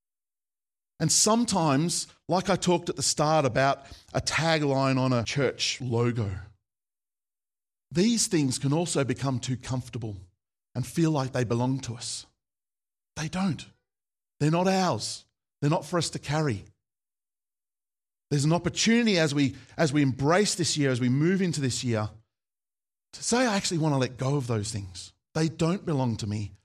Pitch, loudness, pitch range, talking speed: 140 Hz, -26 LUFS, 120-165 Hz, 160 wpm